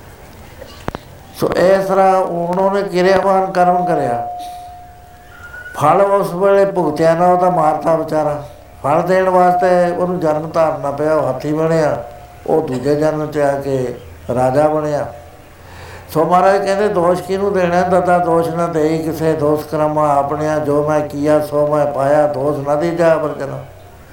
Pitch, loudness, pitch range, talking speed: 155 Hz, -15 LUFS, 145-180 Hz, 140 wpm